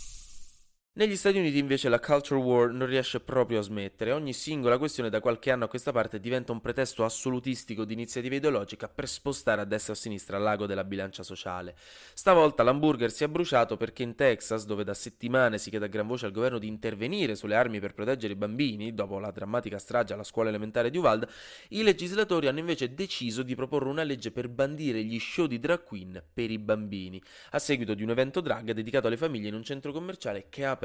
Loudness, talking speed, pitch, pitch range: -29 LUFS, 210 wpm, 120 Hz, 110-135 Hz